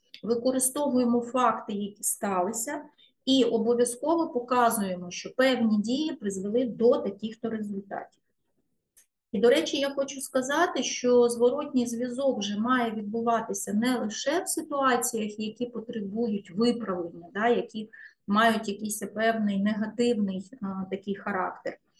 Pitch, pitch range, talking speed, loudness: 235 Hz, 215-255 Hz, 115 wpm, -27 LUFS